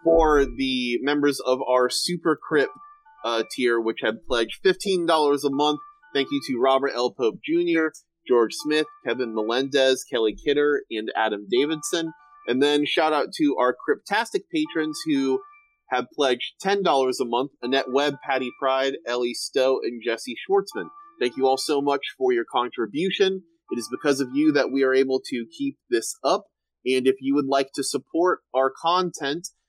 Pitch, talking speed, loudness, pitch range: 145 Hz, 175 wpm, -23 LUFS, 130-180 Hz